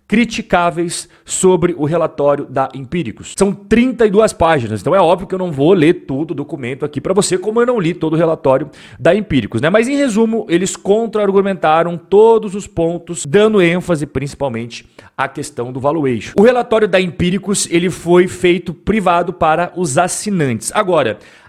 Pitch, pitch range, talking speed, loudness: 175 Hz, 150-200 Hz, 170 wpm, -14 LUFS